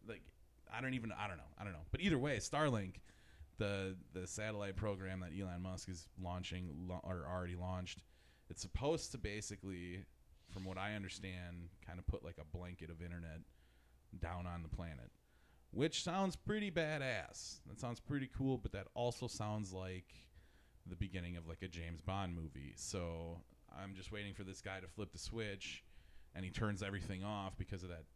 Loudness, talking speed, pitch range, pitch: -45 LUFS, 190 wpm, 85-105 Hz, 95 Hz